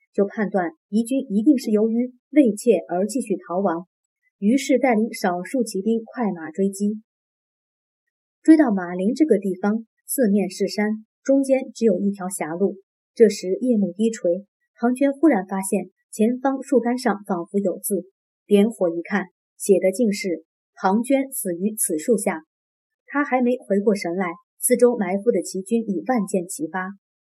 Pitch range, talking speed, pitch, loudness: 190-245 Hz, 230 characters per minute, 210 Hz, -22 LUFS